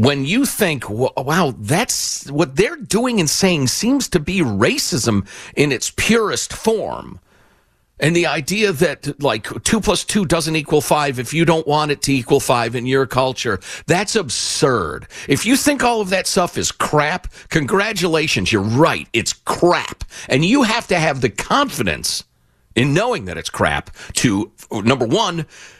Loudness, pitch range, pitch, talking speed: -17 LUFS, 135-185 Hz, 155 Hz, 165 wpm